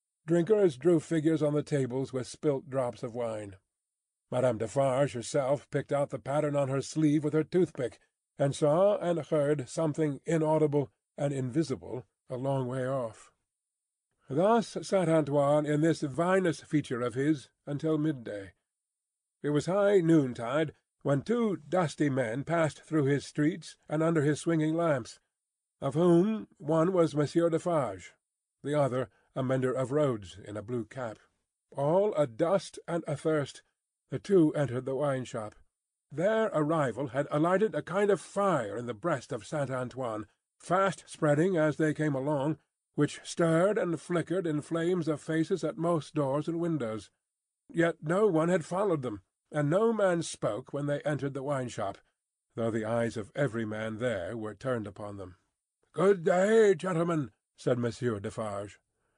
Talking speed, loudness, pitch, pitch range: 160 wpm, -30 LUFS, 150 Hz, 130-165 Hz